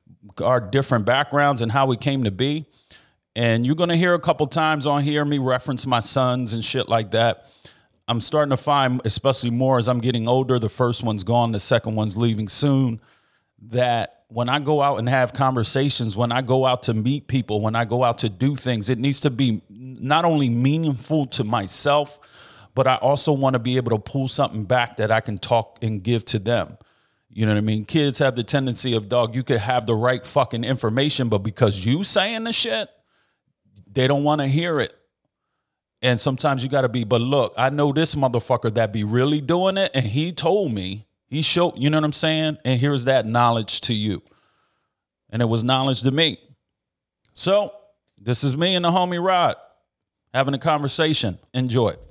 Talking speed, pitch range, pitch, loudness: 205 wpm, 115-145 Hz, 130 Hz, -21 LUFS